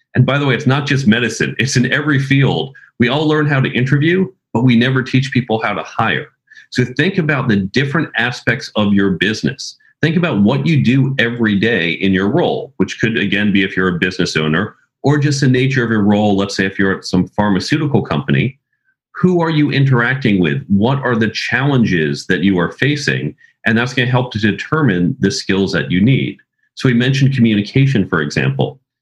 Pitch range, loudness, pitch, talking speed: 100-135 Hz, -15 LUFS, 125 Hz, 205 wpm